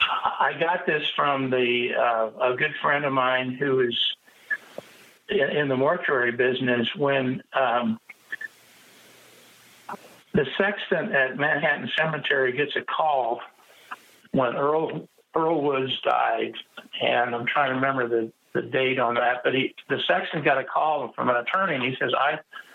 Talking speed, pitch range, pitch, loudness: 150 wpm, 125-145 Hz, 130 Hz, -24 LUFS